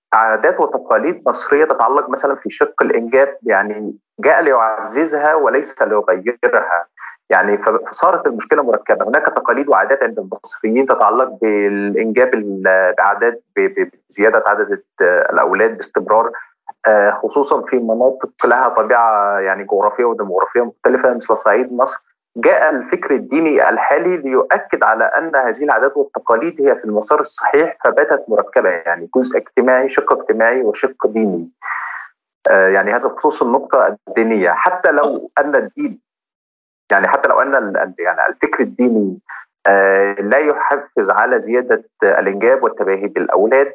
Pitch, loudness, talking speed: 130 Hz, -14 LUFS, 120 wpm